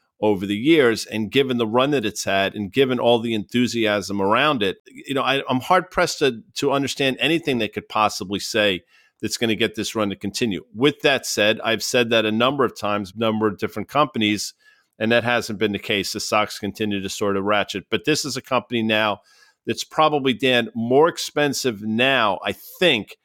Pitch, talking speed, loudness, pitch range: 115 Hz, 205 wpm, -21 LUFS, 105-135 Hz